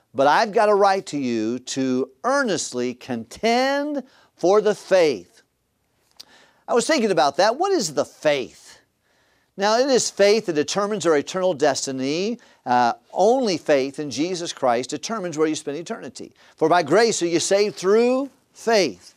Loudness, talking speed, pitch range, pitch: -21 LUFS, 155 wpm, 140-225 Hz, 185 Hz